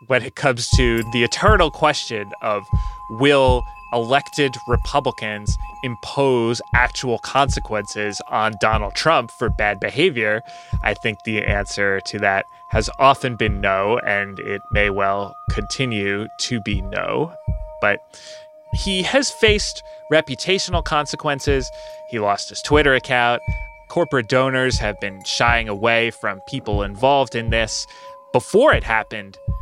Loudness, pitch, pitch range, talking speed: -19 LUFS, 120 Hz, 105-140 Hz, 130 wpm